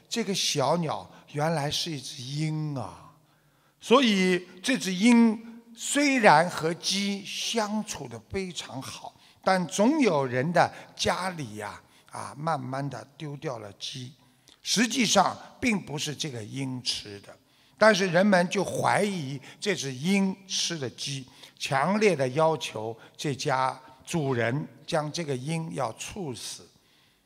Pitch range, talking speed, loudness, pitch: 135-195 Hz, 185 characters per minute, -27 LUFS, 155 Hz